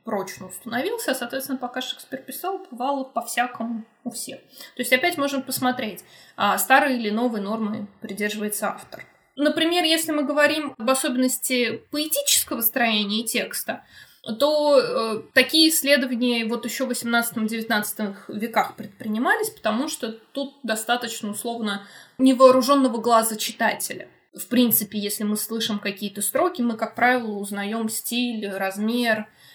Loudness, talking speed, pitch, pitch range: -22 LUFS, 130 wpm, 240 Hz, 220-265 Hz